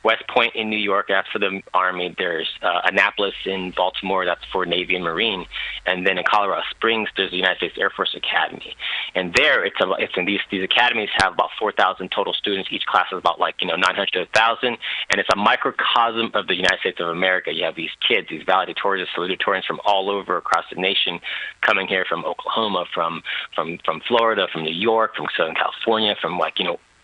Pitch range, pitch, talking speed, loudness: 90-105 Hz, 95 Hz, 215 wpm, -20 LUFS